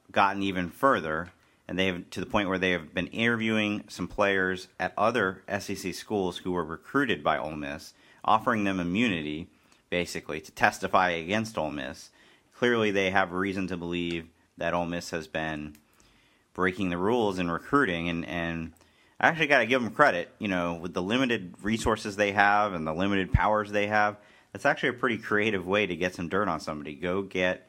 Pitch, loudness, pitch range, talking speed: 95 Hz, -28 LUFS, 85-105 Hz, 190 wpm